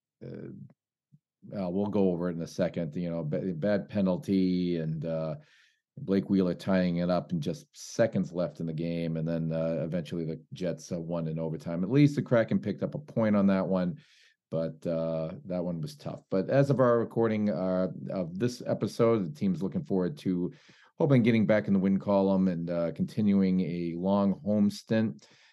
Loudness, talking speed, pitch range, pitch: -29 LUFS, 195 wpm, 85-105 Hz, 95 Hz